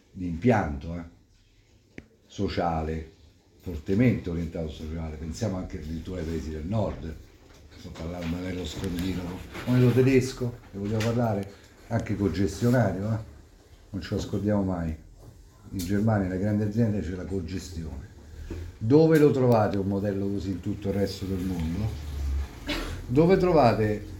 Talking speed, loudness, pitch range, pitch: 140 wpm, -27 LUFS, 85-105 Hz, 95 Hz